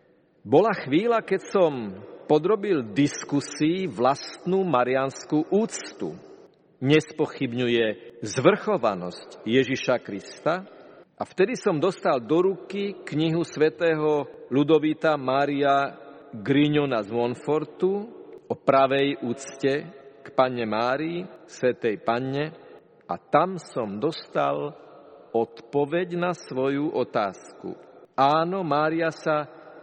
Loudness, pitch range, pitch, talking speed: -25 LUFS, 130-170 Hz, 150 Hz, 90 wpm